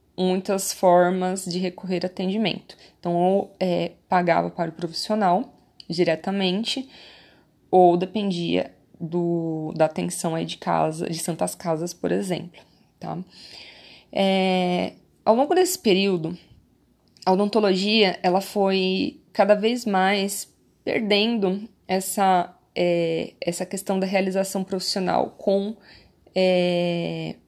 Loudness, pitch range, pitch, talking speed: -23 LUFS, 175-195 Hz, 185 Hz, 110 wpm